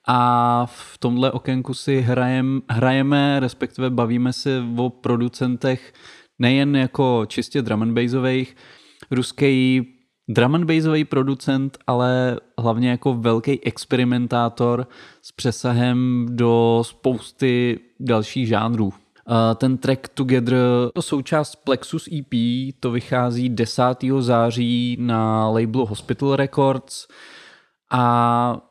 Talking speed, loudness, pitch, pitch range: 95 wpm, -20 LUFS, 125 Hz, 120-135 Hz